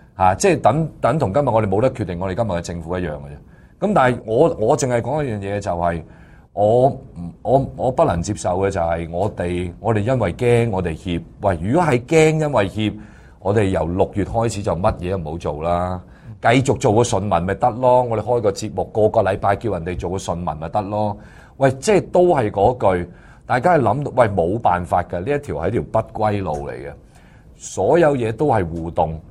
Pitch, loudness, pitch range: 105 Hz, -19 LUFS, 90-125 Hz